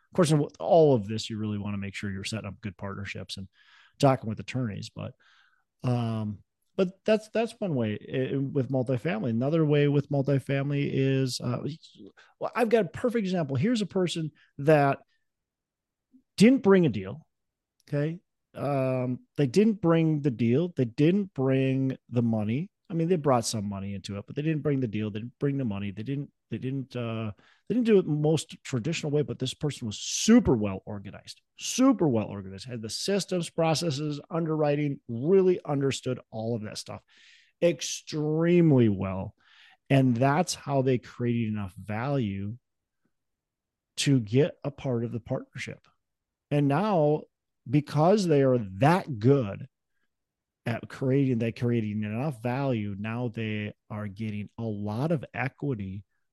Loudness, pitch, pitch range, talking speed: -27 LUFS, 130 Hz, 110-155 Hz, 160 wpm